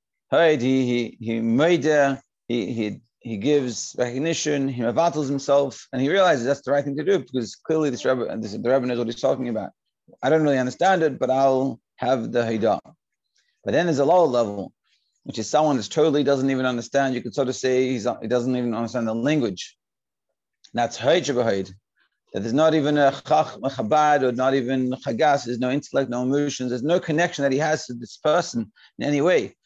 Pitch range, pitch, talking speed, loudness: 120-150 Hz, 135 Hz, 190 wpm, -22 LUFS